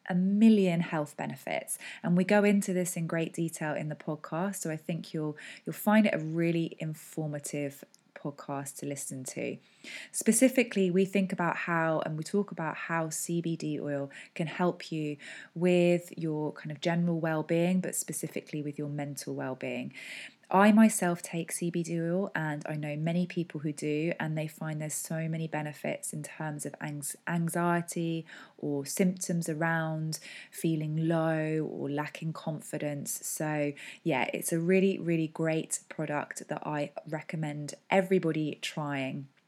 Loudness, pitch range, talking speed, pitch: -31 LUFS, 150-175 Hz, 150 wpm, 160 Hz